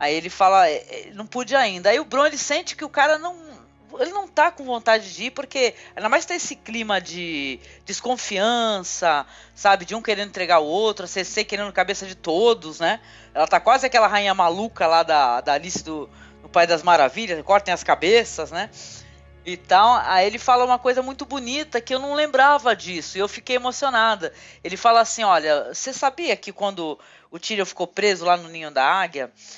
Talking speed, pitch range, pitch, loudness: 200 wpm, 180-260 Hz, 215 Hz, -20 LUFS